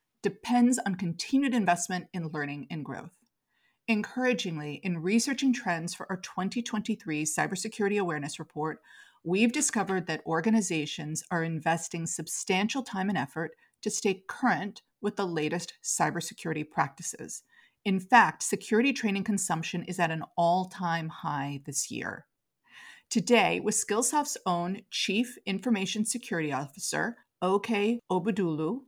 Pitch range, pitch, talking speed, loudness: 165-225 Hz, 190 Hz, 125 wpm, -29 LUFS